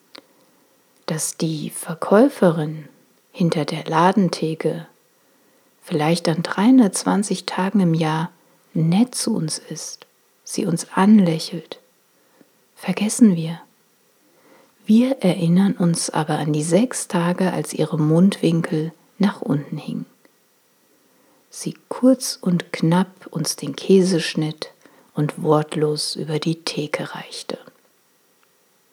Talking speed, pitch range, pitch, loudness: 100 wpm, 160-200 Hz, 175 Hz, -20 LUFS